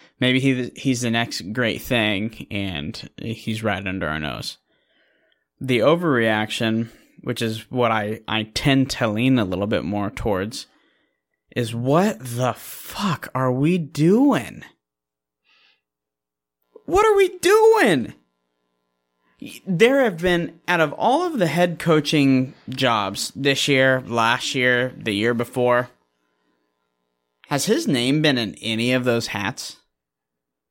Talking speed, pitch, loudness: 130 wpm, 115 Hz, -20 LUFS